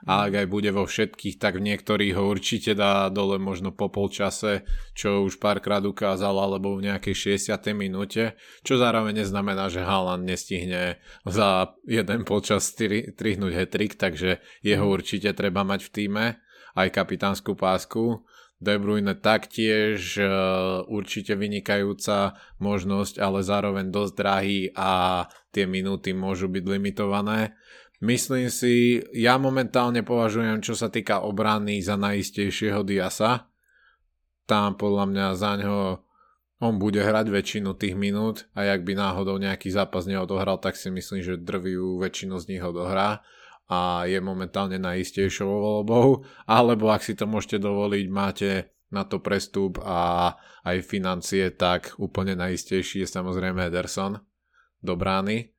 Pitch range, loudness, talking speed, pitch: 95-105 Hz, -25 LUFS, 135 wpm, 100 Hz